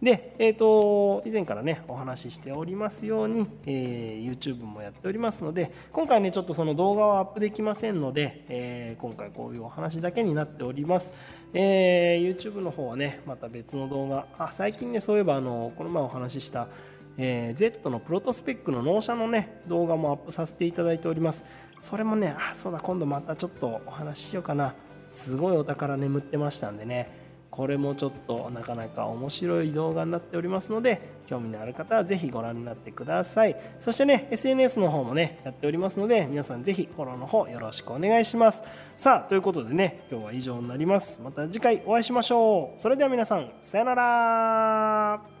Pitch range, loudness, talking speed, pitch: 135-210 Hz, -27 LUFS, 425 characters per minute, 165 Hz